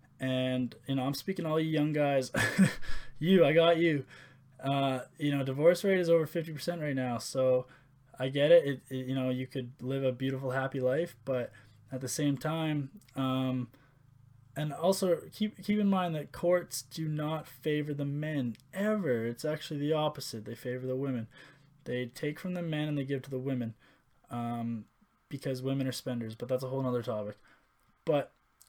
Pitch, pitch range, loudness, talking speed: 135 Hz, 130-155 Hz, -32 LUFS, 190 wpm